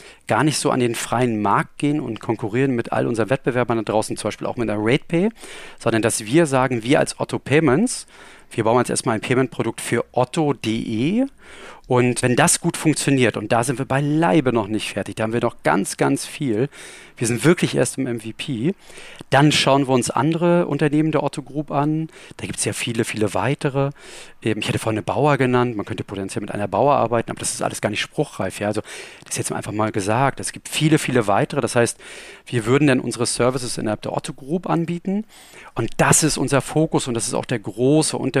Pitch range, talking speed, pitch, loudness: 115-150 Hz, 215 wpm, 130 Hz, -20 LUFS